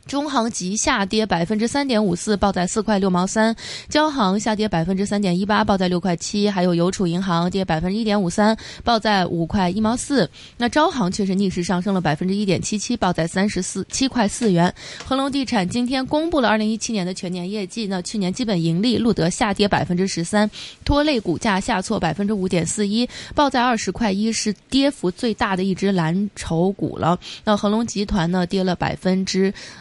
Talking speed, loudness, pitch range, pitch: 320 characters per minute, -20 LUFS, 185-225 Hz, 205 Hz